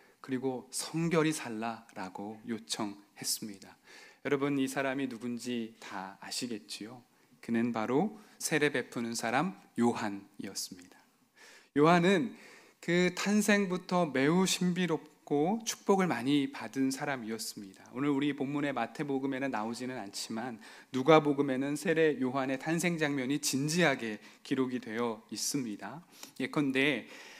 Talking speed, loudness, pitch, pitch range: 285 characters per minute, -32 LUFS, 140 Hz, 120-160 Hz